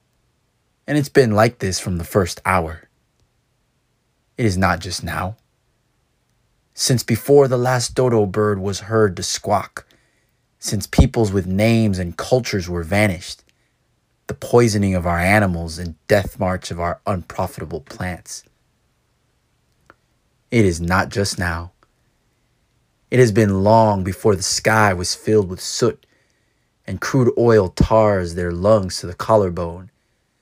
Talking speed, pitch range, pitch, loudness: 135 wpm, 90-110 Hz, 100 Hz, -18 LUFS